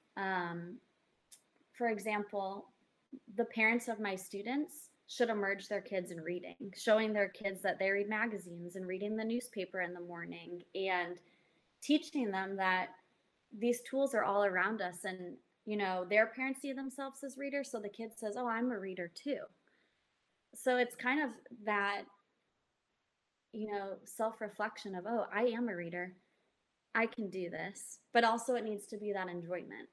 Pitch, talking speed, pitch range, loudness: 210 Hz, 165 wpm, 185-235 Hz, -37 LUFS